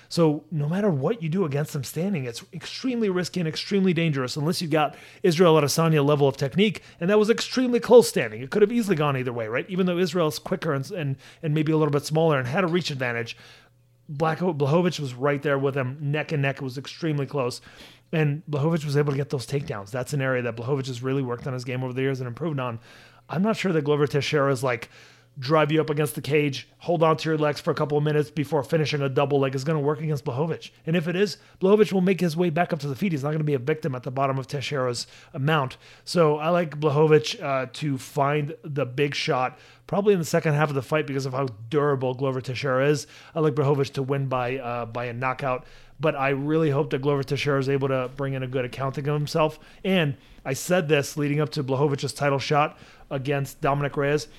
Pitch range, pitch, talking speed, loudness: 135-160 Hz, 145 Hz, 245 wpm, -24 LUFS